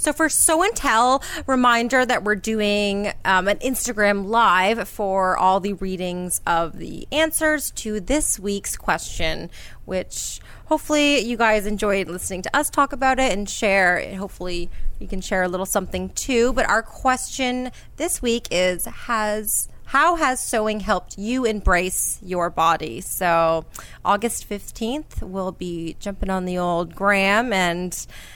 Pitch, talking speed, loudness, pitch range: 205 Hz, 150 wpm, -21 LUFS, 185-250 Hz